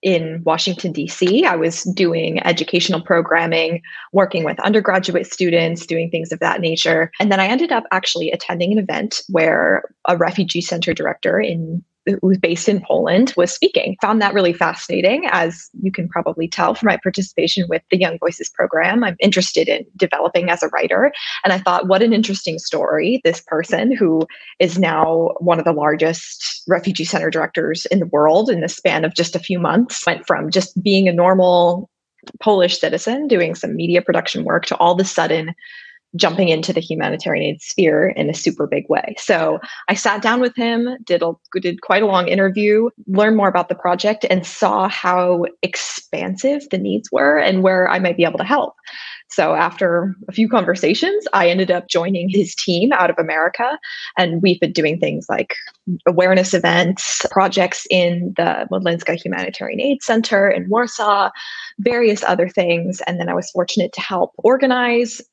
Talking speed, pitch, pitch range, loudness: 180 wpm, 185 Hz, 170-210 Hz, -17 LUFS